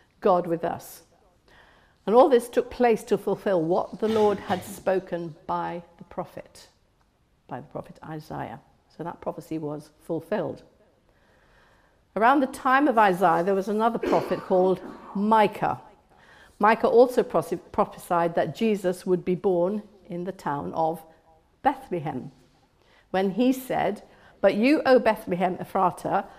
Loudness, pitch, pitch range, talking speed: -24 LUFS, 185 Hz, 170-215 Hz, 135 wpm